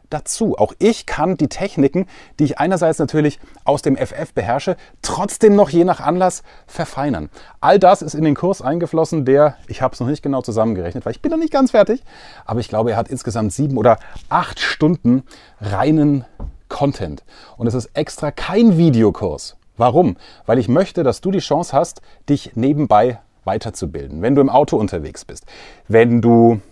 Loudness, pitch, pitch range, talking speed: -17 LUFS, 145 Hz, 120-175 Hz, 180 wpm